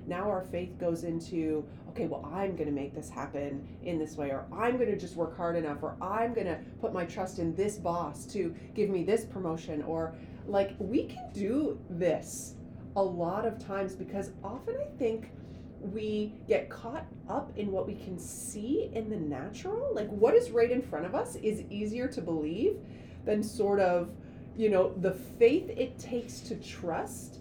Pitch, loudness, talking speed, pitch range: 195 Hz, -33 LUFS, 185 wpm, 165-220 Hz